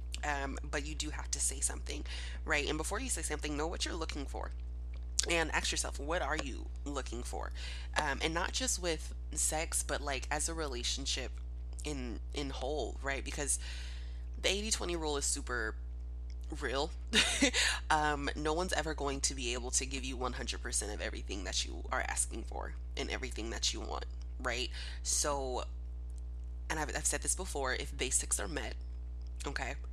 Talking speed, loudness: 180 wpm, -36 LUFS